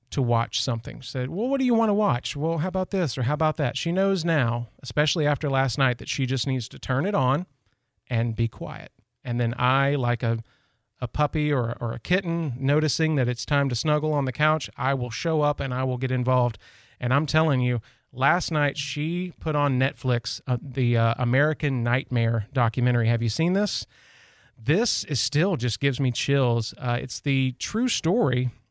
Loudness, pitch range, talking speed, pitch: -25 LUFS, 120-150 Hz, 205 wpm, 135 Hz